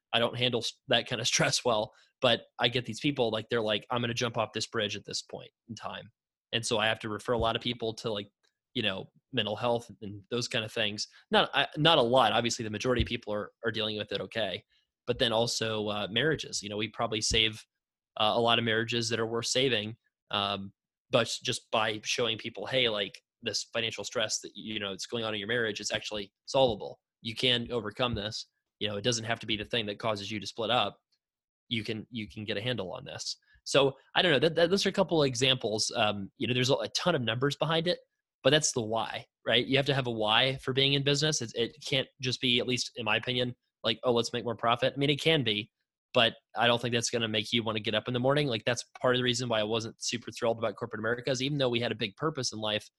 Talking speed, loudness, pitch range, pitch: 265 wpm, -29 LUFS, 110-125 Hz, 115 Hz